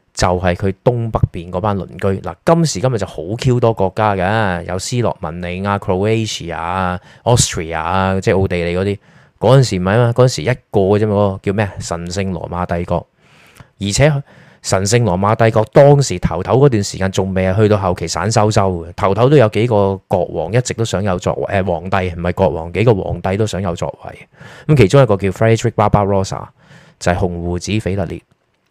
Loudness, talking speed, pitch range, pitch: -15 LUFS, 345 characters per minute, 90-115 Hz, 100 Hz